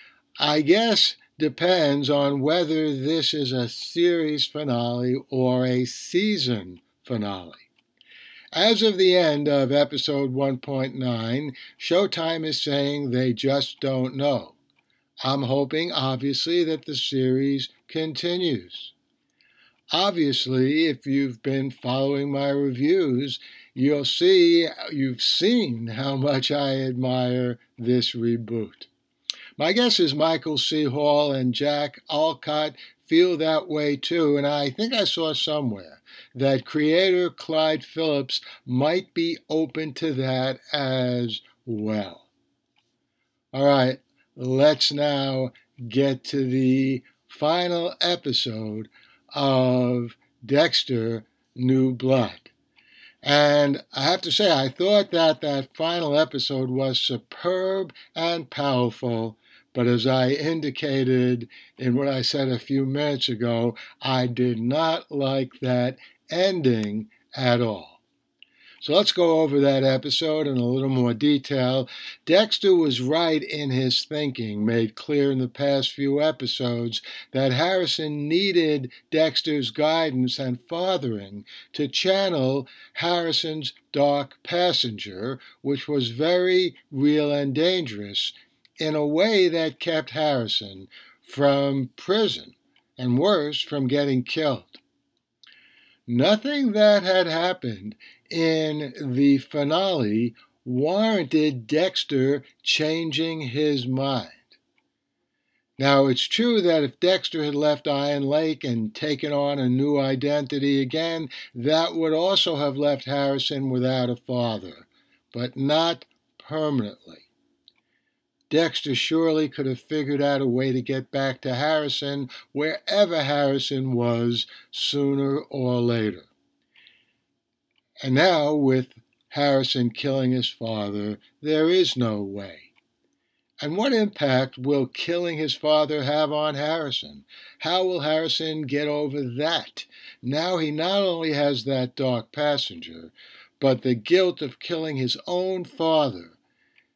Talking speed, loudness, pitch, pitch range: 120 wpm, -23 LUFS, 140 Hz, 130-155 Hz